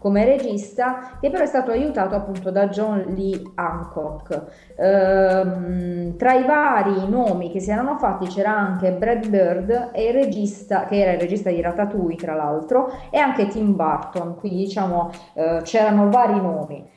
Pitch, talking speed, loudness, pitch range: 195 Hz, 150 wpm, -20 LUFS, 180-230 Hz